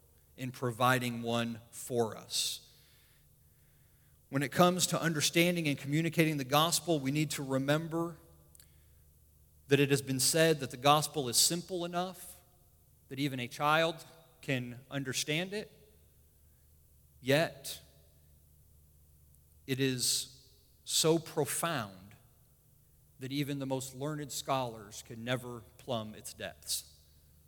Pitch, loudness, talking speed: 130 Hz, -32 LUFS, 115 wpm